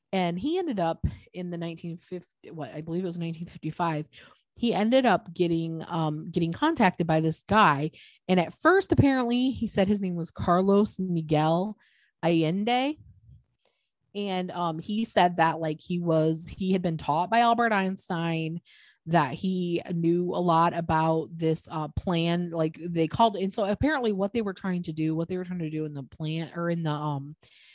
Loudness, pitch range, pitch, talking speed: -27 LUFS, 160-195 Hz, 170 Hz, 185 wpm